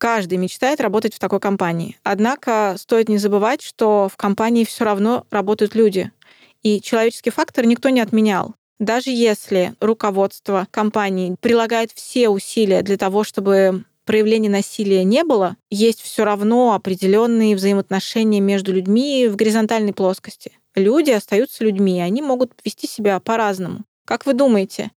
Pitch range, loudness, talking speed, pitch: 200-230 Hz, -18 LUFS, 140 wpm, 215 Hz